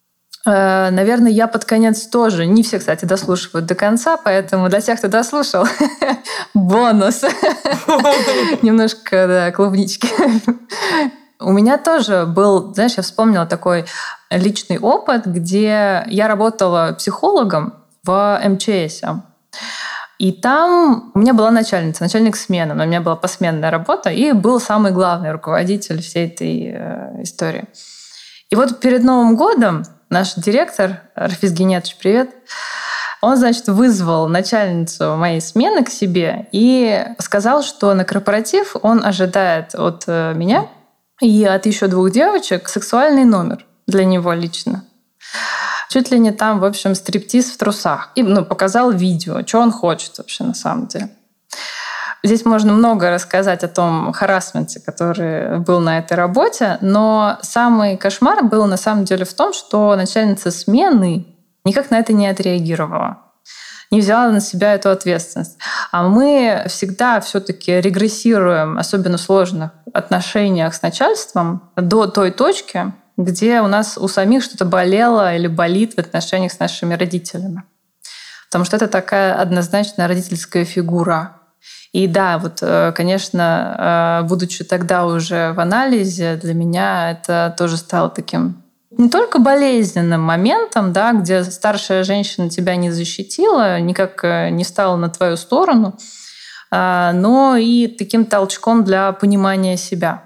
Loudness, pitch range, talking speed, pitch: -15 LUFS, 180-225 Hz, 135 wpm, 195 Hz